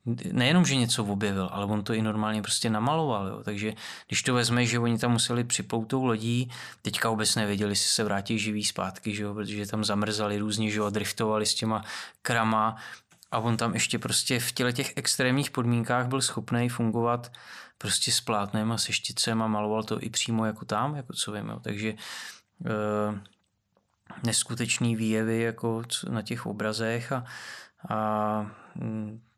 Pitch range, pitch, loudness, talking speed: 105-120 Hz, 110 Hz, -28 LUFS, 165 wpm